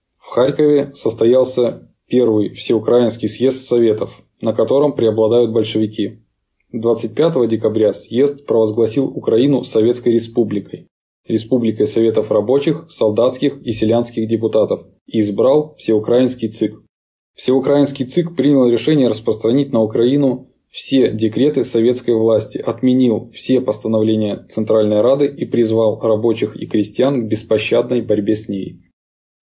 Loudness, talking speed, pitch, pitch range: -16 LUFS, 110 wpm, 115 Hz, 110-130 Hz